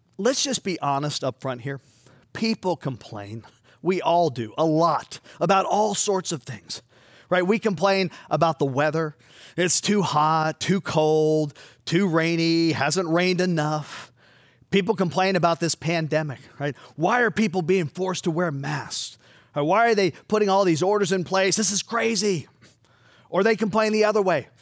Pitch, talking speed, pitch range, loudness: 170 Hz, 165 wpm, 145-195 Hz, -23 LUFS